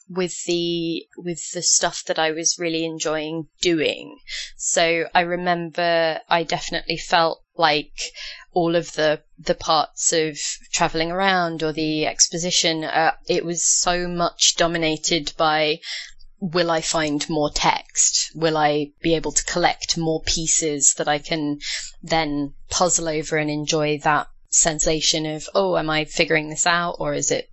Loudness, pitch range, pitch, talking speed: -20 LUFS, 155-175 Hz, 165 Hz, 150 wpm